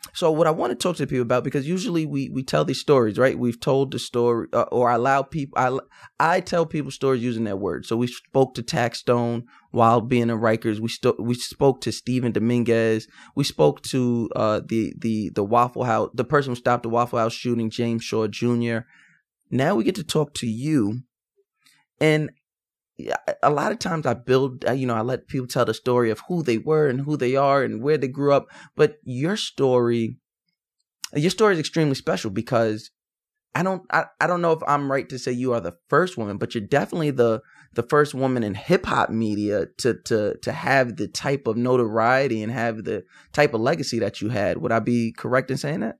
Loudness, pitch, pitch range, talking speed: -23 LUFS, 125 Hz, 115-145 Hz, 215 wpm